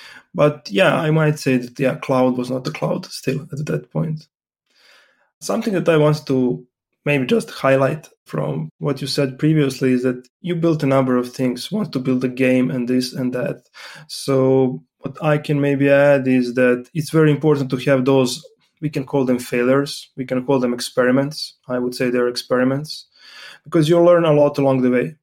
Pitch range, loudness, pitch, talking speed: 125-150 Hz, -18 LUFS, 135 Hz, 195 wpm